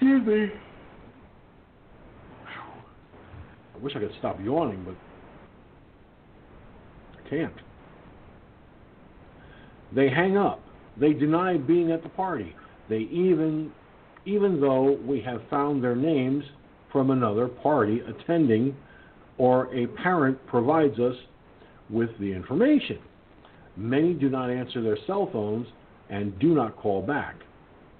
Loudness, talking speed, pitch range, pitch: -26 LUFS, 115 wpm, 125-165 Hz, 140 Hz